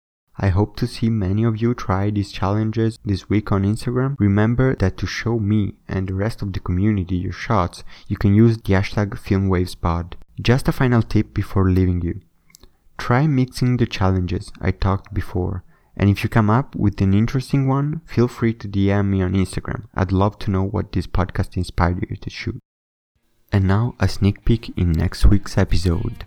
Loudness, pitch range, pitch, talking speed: -20 LUFS, 95-115 Hz, 100 Hz, 190 wpm